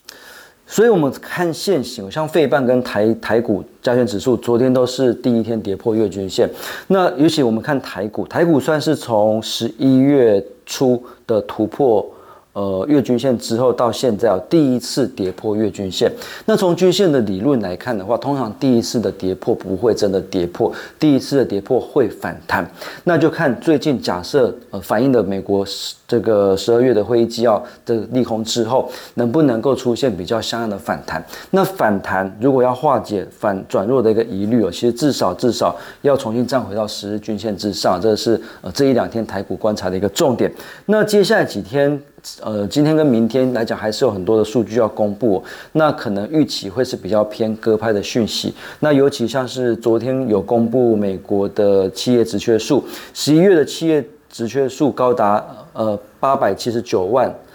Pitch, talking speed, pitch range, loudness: 115 Hz, 280 characters per minute, 105-130 Hz, -17 LUFS